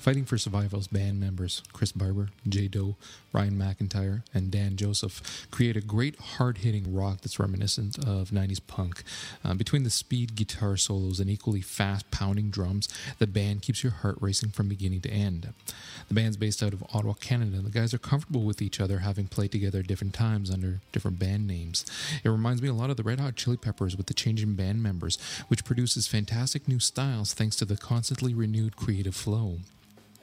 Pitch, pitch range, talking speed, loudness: 105 Hz, 100-115 Hz, 195 wpm, -29 LUFS